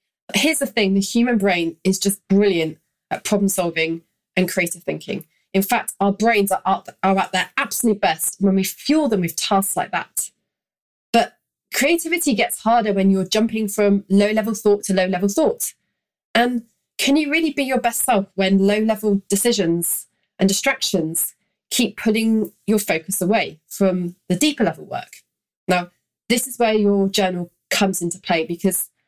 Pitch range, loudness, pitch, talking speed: 185-225 Hz, -19 LUFS, 200 Hz, 170 wpm